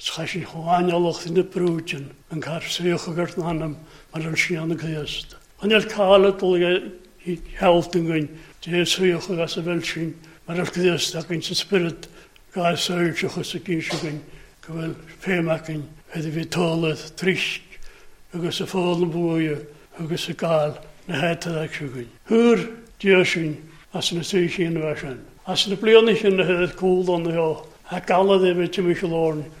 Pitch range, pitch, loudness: 160-180 Hz, 170 Hz, -22 LUFS